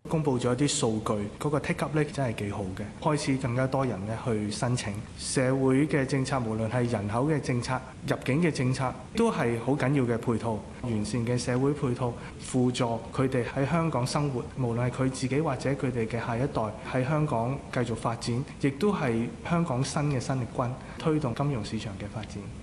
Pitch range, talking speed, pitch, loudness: 115-140 Hz, 295 characters per minute, 130 Hz, -29 LUFS